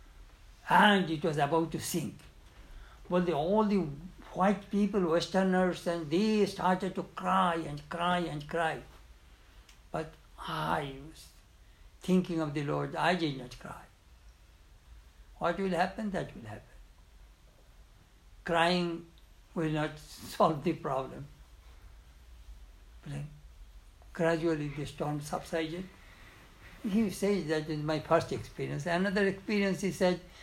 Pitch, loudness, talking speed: 155 Hz, -31 LUFS, 120 wpm